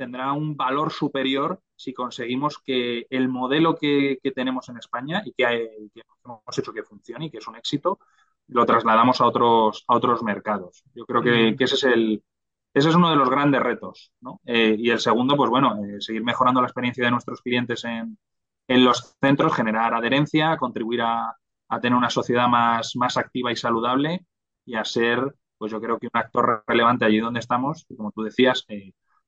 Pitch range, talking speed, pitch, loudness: 115-135 Hz, 200 wpm, 120 Hz, -22 LUFS